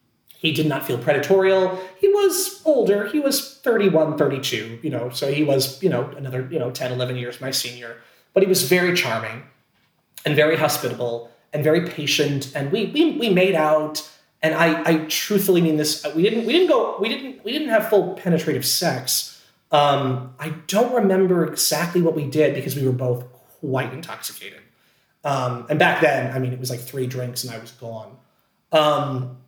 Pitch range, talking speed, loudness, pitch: 130-185 Hz, 190 wpm, -20 LUFS, 155 Hz